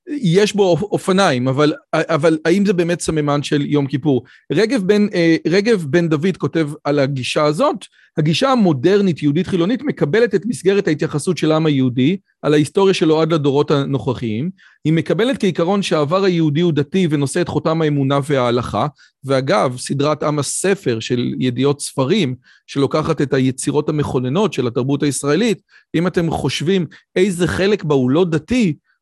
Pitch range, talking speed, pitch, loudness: 145-185 Hz, 150 wpm, 160 Hz, -17 LUFS